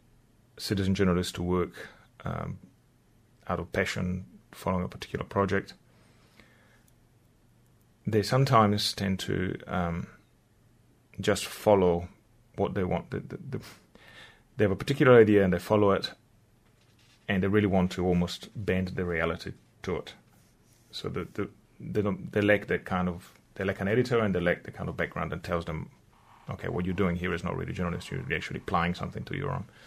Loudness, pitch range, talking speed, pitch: -29 LUFS, 90-115 Hz, 170 wpm, 100 Hz